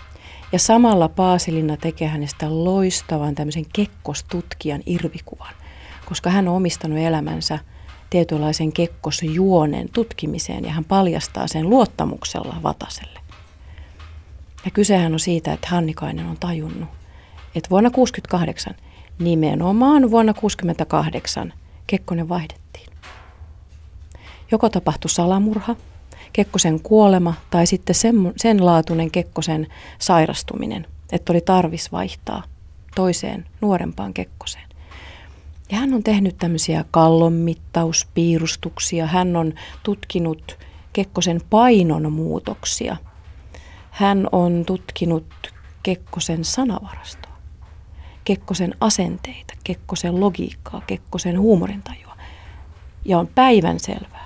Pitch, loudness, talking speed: 165 Hz, -19 LUFS, 95 wpm